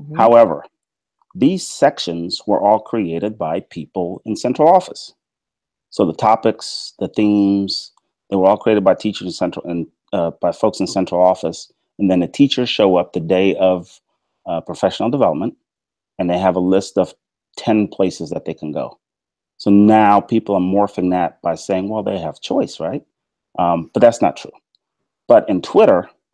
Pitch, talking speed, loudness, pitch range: 95 Hz, 175 wpm, -17 LUFS, 90-105 Hz